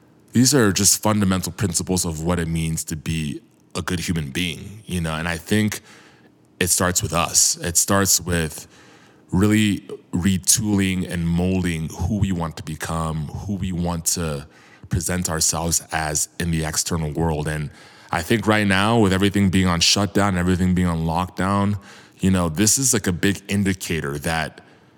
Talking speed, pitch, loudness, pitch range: 170 wpm, 90 Hz, -20 LUFS, 80-100 Hz